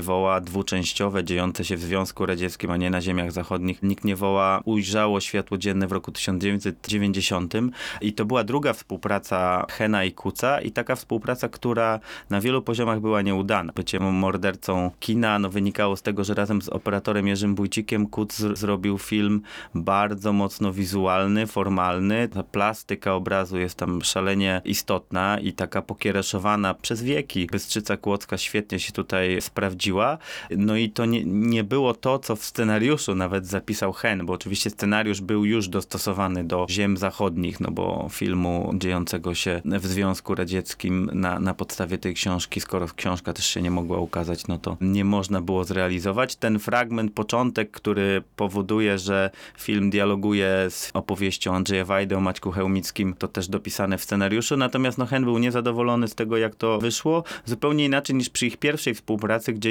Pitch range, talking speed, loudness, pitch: 95-110 Hz, 165 wpm, -24 LUFS, 100 Hz